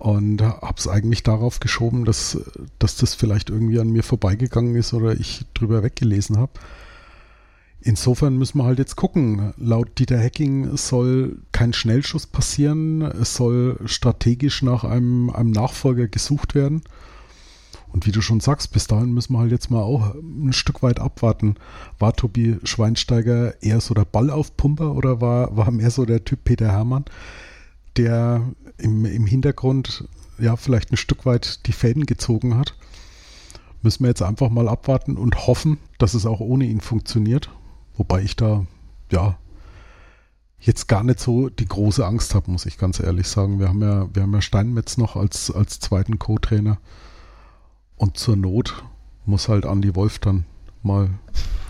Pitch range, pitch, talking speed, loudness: 100-125 Hz, 115 Hz, 165 wpm, -20 LUFS